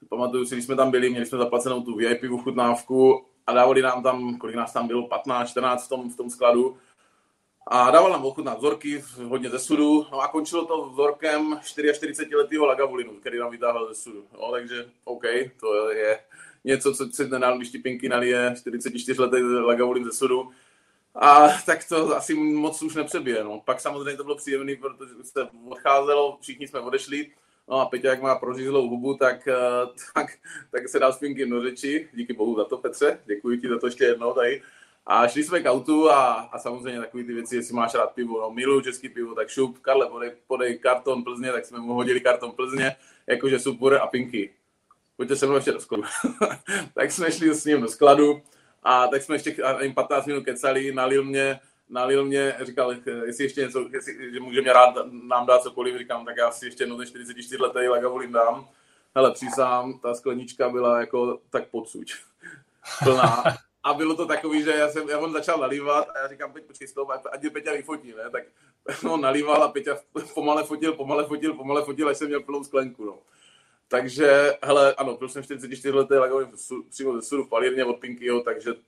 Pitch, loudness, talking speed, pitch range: 130 Hz, -23 LUFS, 195 wpm, 125-145 Hz